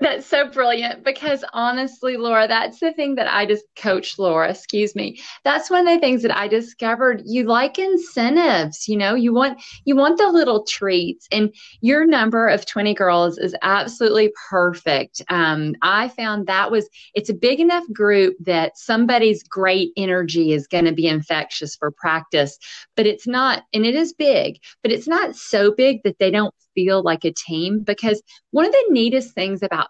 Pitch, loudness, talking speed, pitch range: 215 Hz, -19 LUFS, 185 wpm, 190-260 Hz